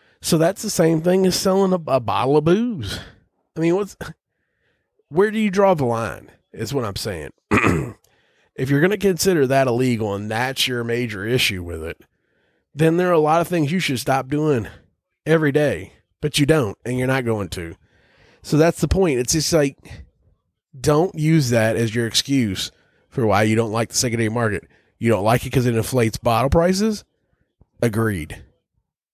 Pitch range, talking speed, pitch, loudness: 110-160 Hz, 190 wpm, 130 Hz, -20 LUFS